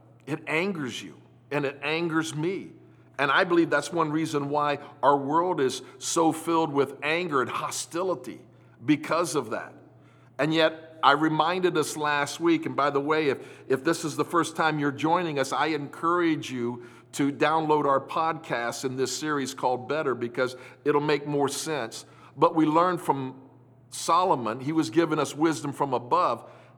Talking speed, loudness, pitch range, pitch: 170 wpm, -26 LUFS, 140-160 Hz, 150 Hz